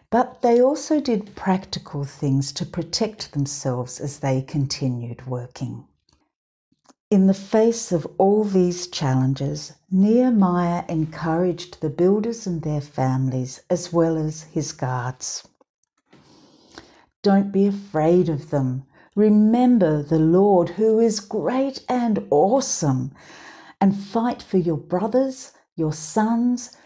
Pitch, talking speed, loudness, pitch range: 175 Hz, 115 wpm, -21 LUFS, 145-220 Hz